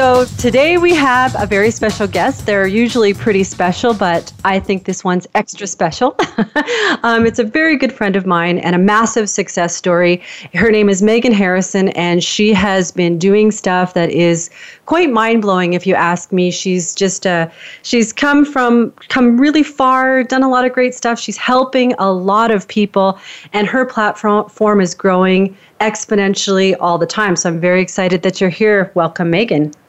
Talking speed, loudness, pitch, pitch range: 185 wpm, -13 LUFS, 205 Hz, 180-235 Hz